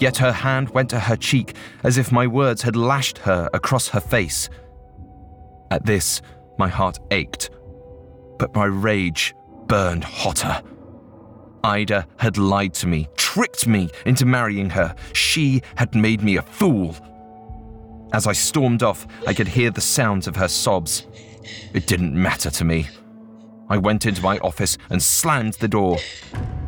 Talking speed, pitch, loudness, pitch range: 155 wpm, 110 Hz, -20 LUFS, 95-120 Hz